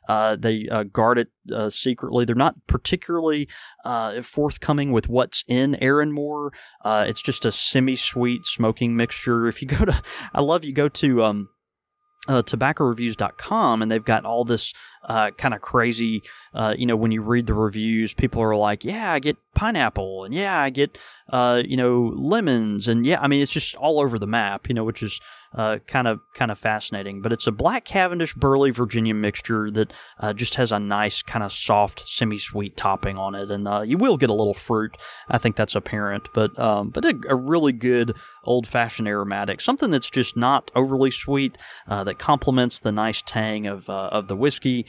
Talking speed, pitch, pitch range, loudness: 195 wpm, 115 Hz, 110-135 Hz, -22 LUFS